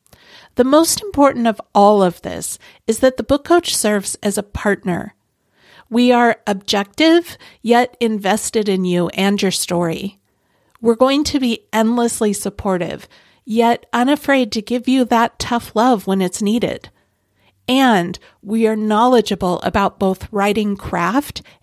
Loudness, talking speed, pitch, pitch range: -16 LUFS, 140 wpm, 220 Hz, 200-245 Hz